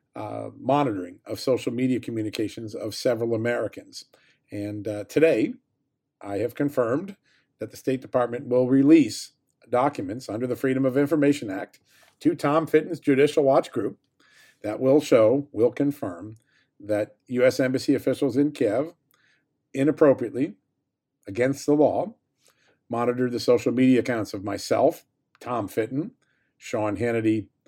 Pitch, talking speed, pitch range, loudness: 130 Hz, 130 wpm, 115-145 Hz, -24 LUFS